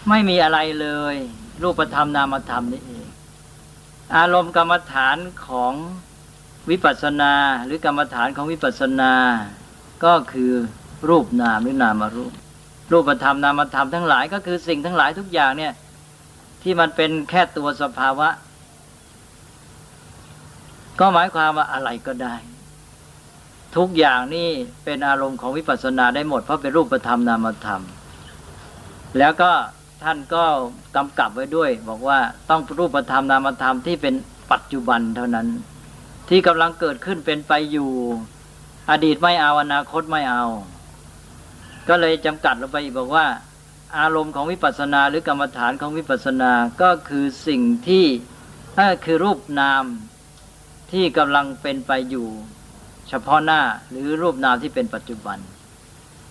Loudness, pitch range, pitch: -19 LUFS, 125-165 Hz, 145 Hz